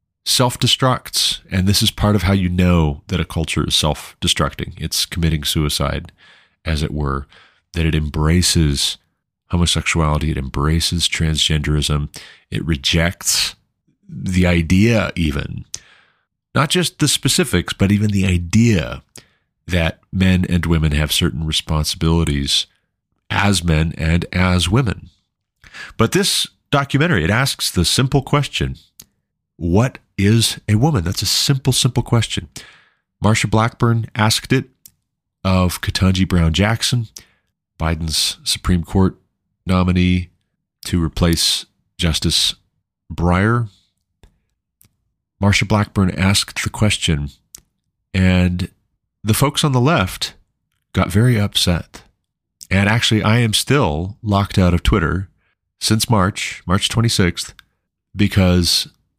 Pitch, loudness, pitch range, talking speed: 95 Hz, -17 LUFS, 85-110 Hz, 115 wpm